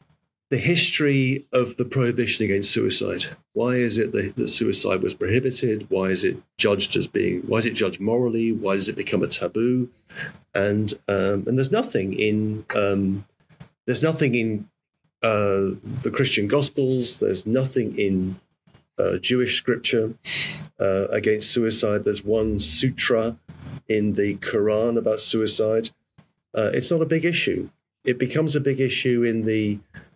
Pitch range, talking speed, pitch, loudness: 105-130 Hz, 150 wpm, 115 Hz, -22 LUFS